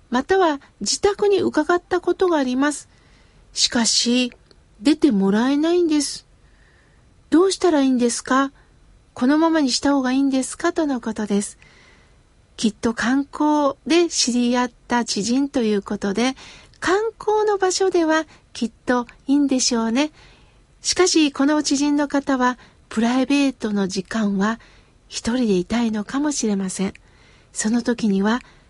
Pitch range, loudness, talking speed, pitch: 230-305 Hz, -20 LUFS, 285 characters per minute, 265 Hz